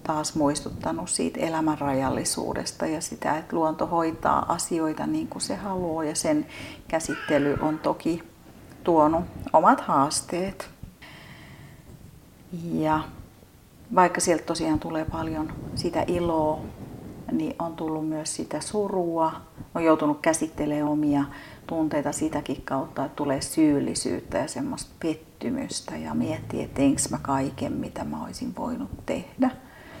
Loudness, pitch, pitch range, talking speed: -26 LUFS, 155 Hz, 150-170 Hz, 120 wpm